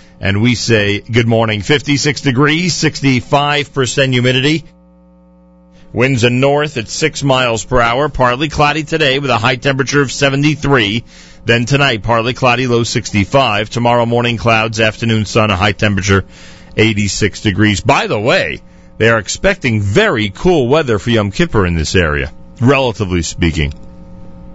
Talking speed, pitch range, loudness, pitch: 145 wpm, 105-140 Hz, -13 LUFS, 115 Hz